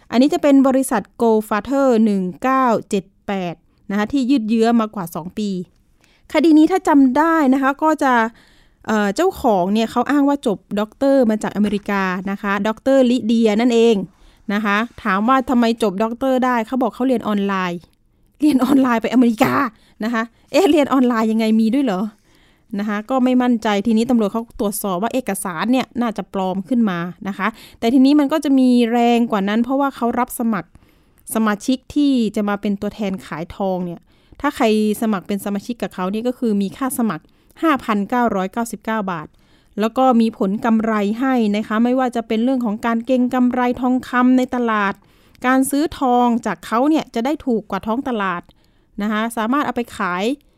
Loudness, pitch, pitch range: -18 LUFS, 230 Hz, 205-255 Hz